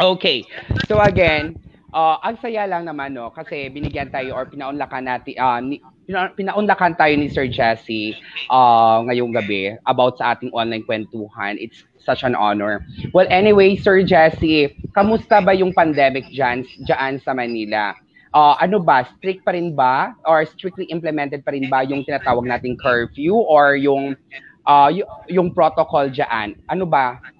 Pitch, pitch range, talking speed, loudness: 140 Hz, 125-175 Hz, 160 wpm, -17 LUFS